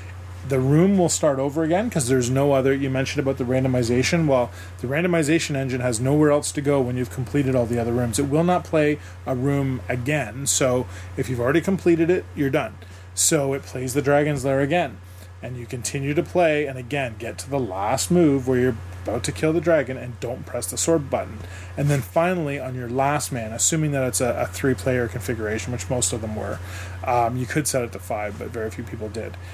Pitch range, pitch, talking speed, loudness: 115-145 Hz, 130 Hz, 225 wpm, -22 LUFS